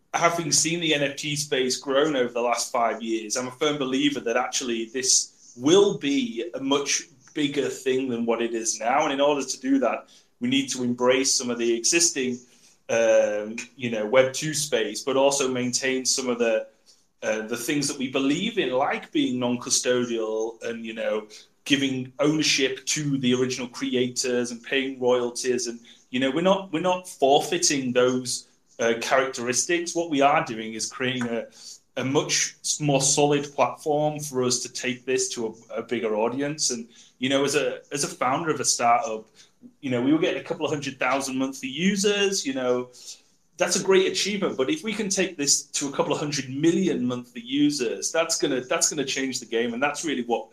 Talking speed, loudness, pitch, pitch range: 195 wpm, -24 LUFS, 130 Hz, 120-150 Hz